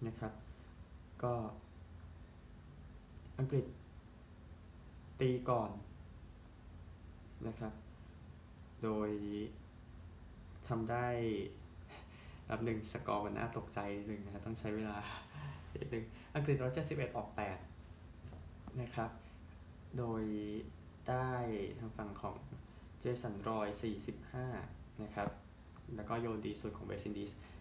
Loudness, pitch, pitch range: -42 LUFS, 105 Hz, 85-115 Hz